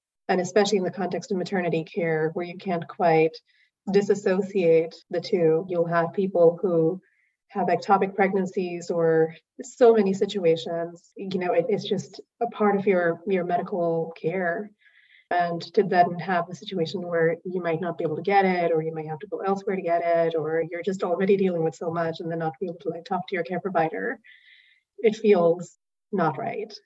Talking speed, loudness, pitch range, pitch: 195 wpm, -25 LUFS, 165-195 Hz, 175 Hz